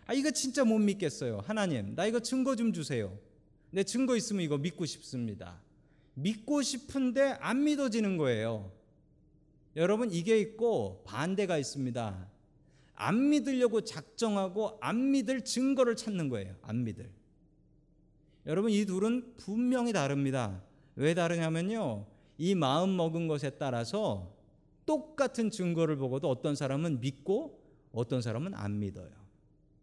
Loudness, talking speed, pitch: -32 LUFS, 280 characters per minute, 165 Hz